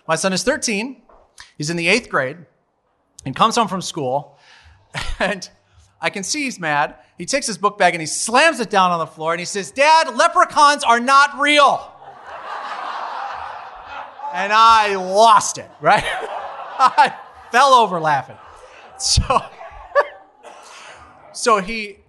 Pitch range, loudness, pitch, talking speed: 175-275 Hz, -17 LUFS, 220 Hz, 145 wpm